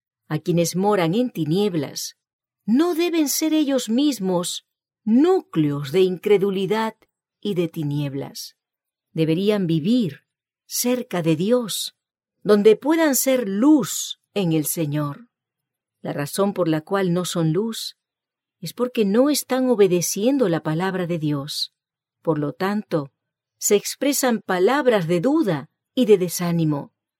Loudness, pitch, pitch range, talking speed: -21 LUFS, 190 Hz, 160-245 Hz, 125 wpm